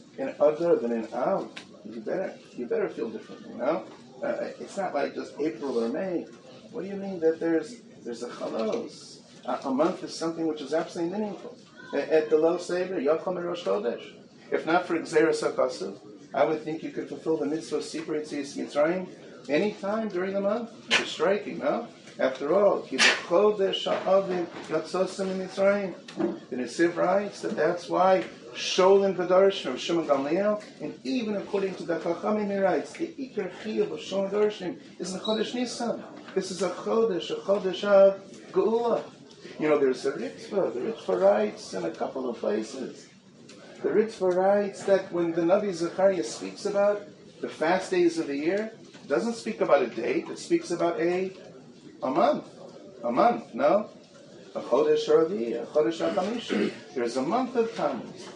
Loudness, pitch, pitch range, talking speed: -27 LUFS, 190 Hz, 165-210 Hz, 170 wpm